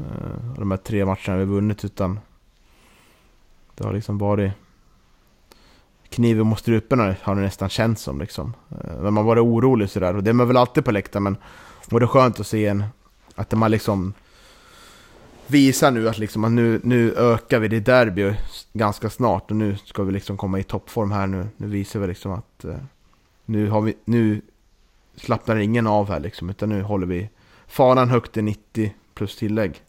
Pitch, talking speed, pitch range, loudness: 105 Hz, 190 wpm, 100-115 Hz, -21 LUFS